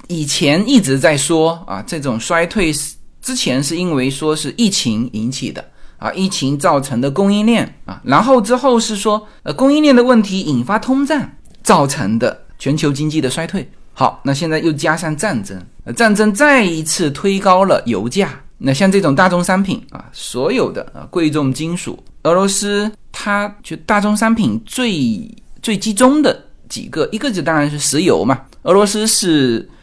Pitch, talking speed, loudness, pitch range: 185 Hz, 260 characters per minute, -15 LUFS, 150-215 Hz